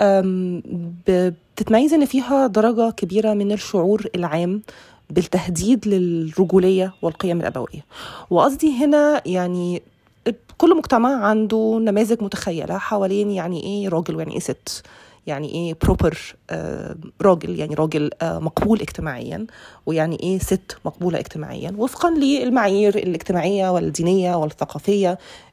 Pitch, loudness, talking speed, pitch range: 190 Hz, -20 LUFS, 110 wpm, 175-220 Hz